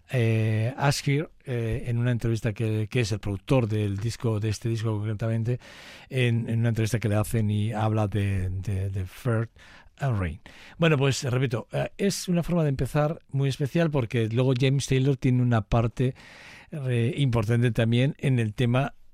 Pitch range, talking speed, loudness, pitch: 110-135 Hz, 175 wpm, -26 LUFS, 120 Hz